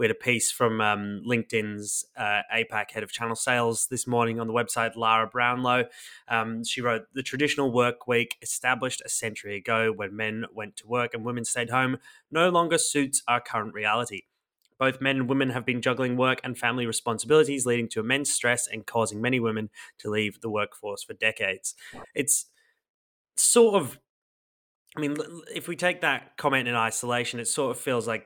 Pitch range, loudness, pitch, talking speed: 115-130 Hz, -26 LUFS, 120 Hz, 185 wpm